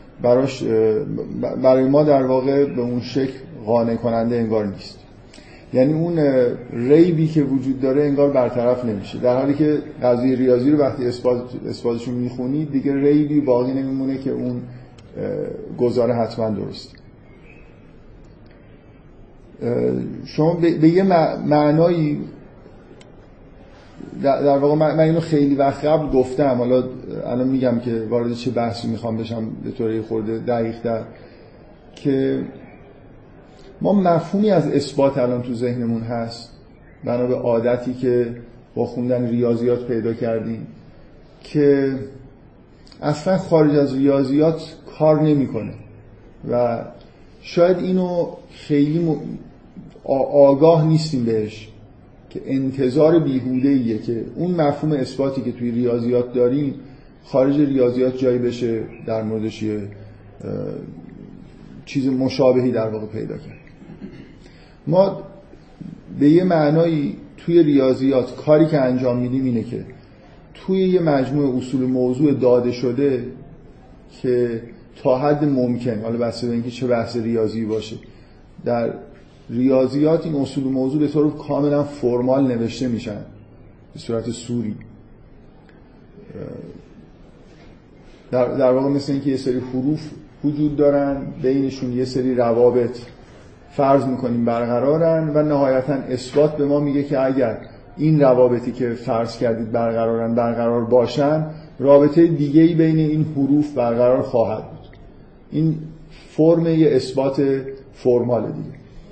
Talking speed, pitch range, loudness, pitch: 120 wpm, 120-145 Hz, -19 LUFS, 130 Hz